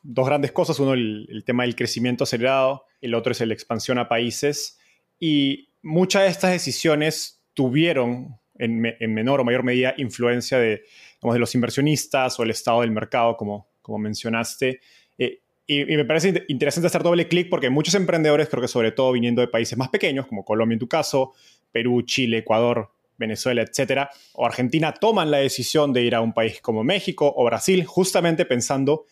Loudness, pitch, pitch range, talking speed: -22 LUFS, 130 Hz, 120-150 Hz, 190 wpm